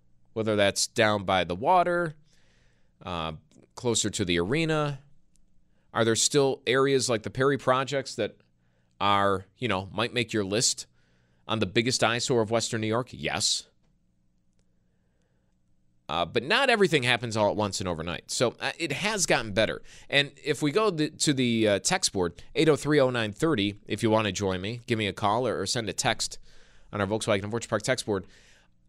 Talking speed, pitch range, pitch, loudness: 180 wpm, 85-130 Hz, 110 Hz, -26 LUFS